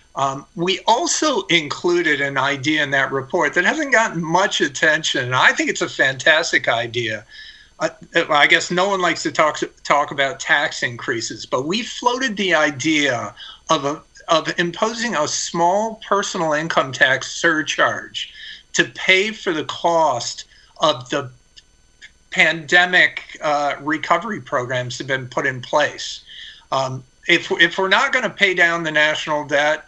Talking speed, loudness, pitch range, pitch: 155 wpm, -18 LUFS, 150-195 Hz, 170 Hz